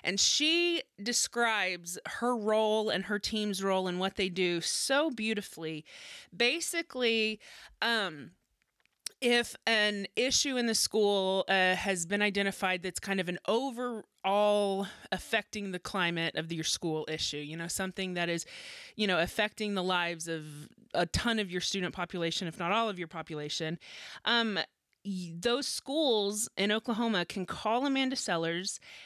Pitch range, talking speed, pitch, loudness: 175-225 Hz, 145 wpm, 195 Hz, -31 LUFS